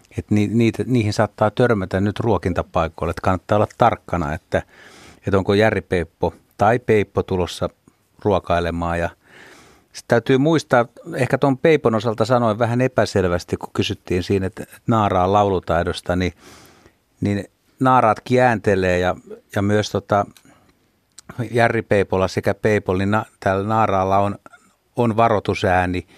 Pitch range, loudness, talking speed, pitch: 95-115 Hz, -19 LUFS, 115 wpm, 105 Hz